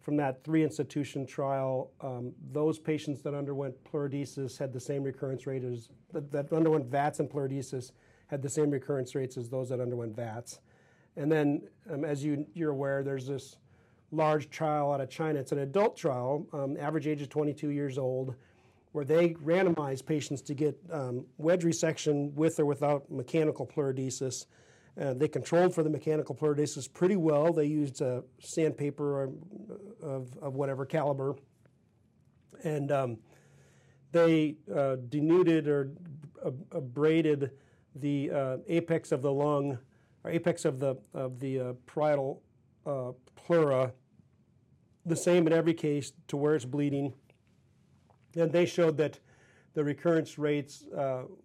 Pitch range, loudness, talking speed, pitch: 135-155 Hz, -31 LUFS, 155 wpm, 145 Hz